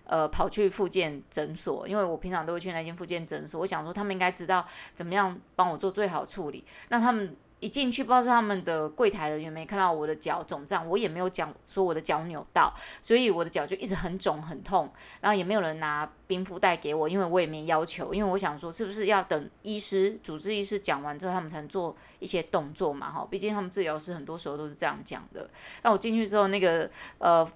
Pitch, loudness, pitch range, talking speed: 185 Hz, -29 LUFS, 165-200 Hz, 355 characters per minute